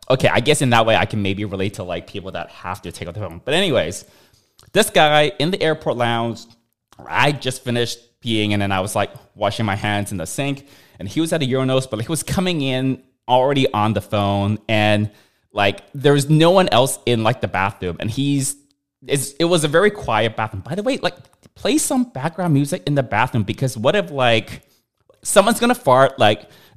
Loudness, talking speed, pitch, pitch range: -19 LUFS, 220 wpm, 120 Hz, 105-140 Hz